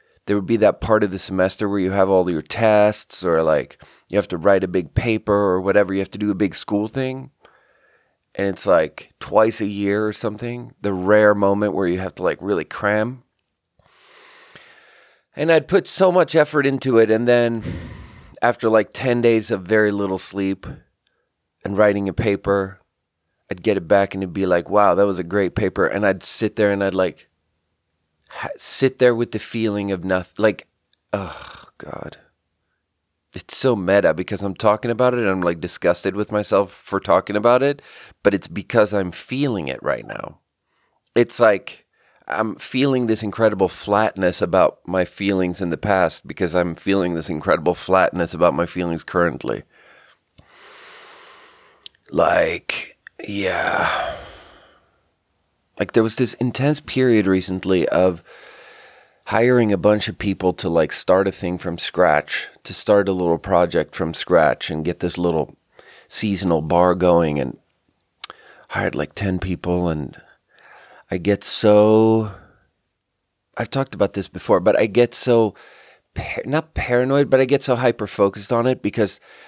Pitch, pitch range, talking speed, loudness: 100 Hz, 90-115 Hz, 165 wpm, -19 LUFS